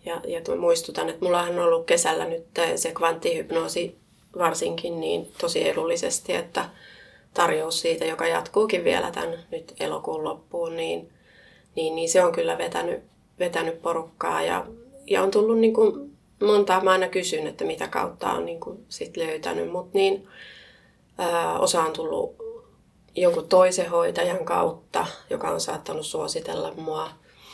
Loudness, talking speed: -25 LUFS, 145 wpm